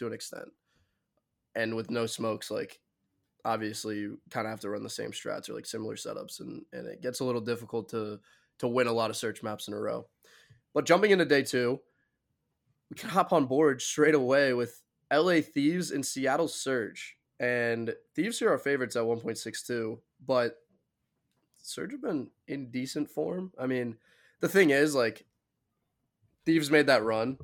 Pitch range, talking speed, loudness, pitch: 115-140 Hz, 180 wpm, -30 LUFS, 125 Hz